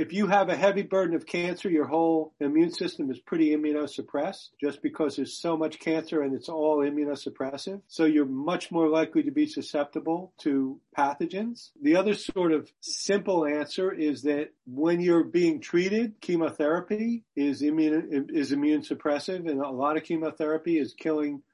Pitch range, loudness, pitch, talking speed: 150-190 Hz, -27 LUFS, 160 Hz, 165 wpm